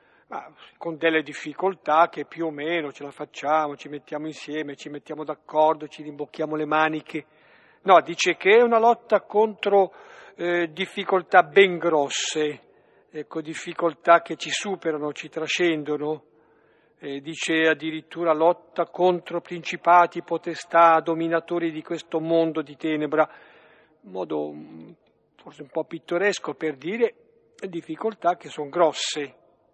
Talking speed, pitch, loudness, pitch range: 130 wpm, 160 Hz, -23 LUFS, 150-175 Hz